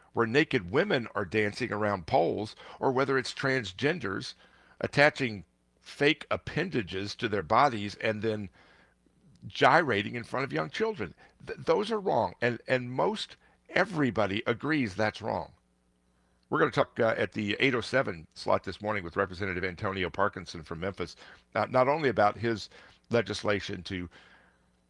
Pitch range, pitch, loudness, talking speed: 95-125 Hz, 105 Hz, -29 LUFS, 140 wpm